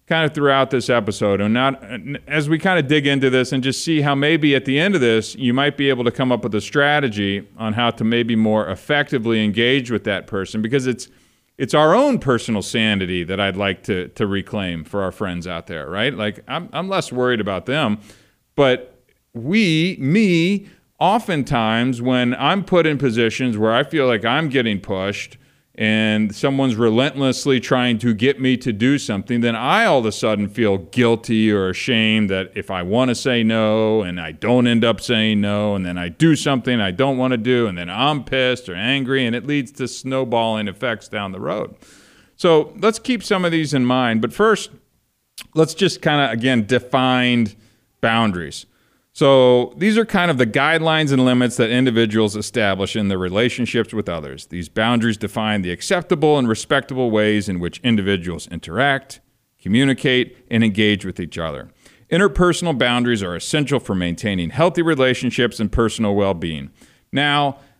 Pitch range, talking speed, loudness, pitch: 105-140 Hz, 185 wpm, -18 LUFS, 125 Hz